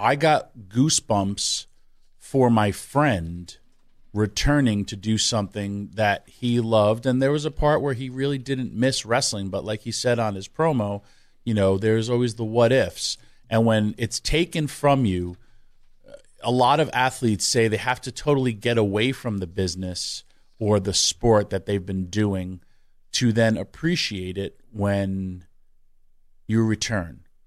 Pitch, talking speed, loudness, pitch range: 110 Hz, 155 wpm, -23 LUFS, 100-125 Hz